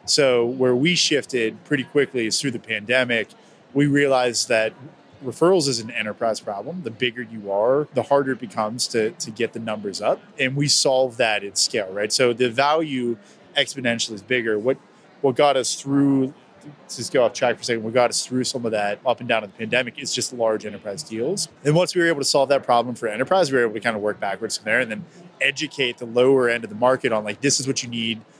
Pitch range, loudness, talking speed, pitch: 115-140 Hz, -21 LUFS, 240 wpm, 125 Hz